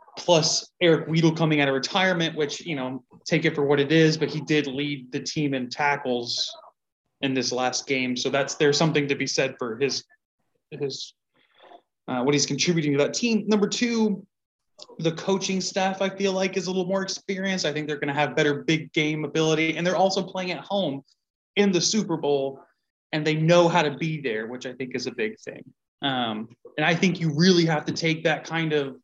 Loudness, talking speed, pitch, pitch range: -24 LUFS, 215 wpm, 155 Hz, 140-185 Hz